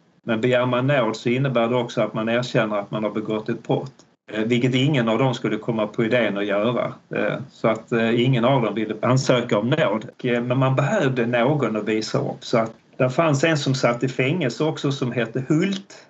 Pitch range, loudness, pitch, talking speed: 115-135 Hz, -22 LUFS, 125 Hz, 210 wpm